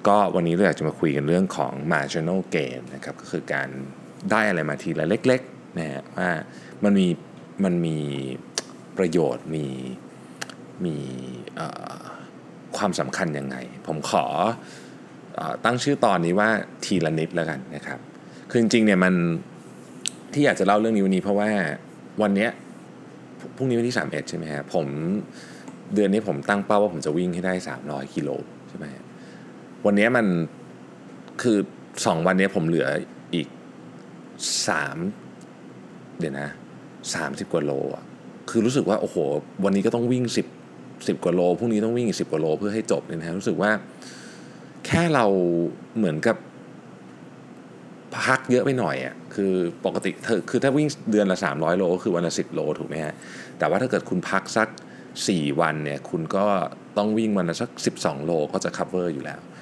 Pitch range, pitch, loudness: 75-105 Hz, 90 Hz, -24 LUFS